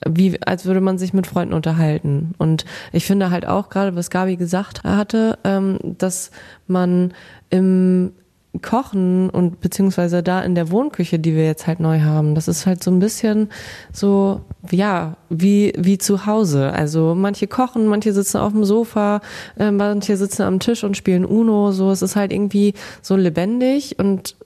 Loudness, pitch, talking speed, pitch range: -18 LUFS, 190 Hz, 170 wpm, 175-205 Hz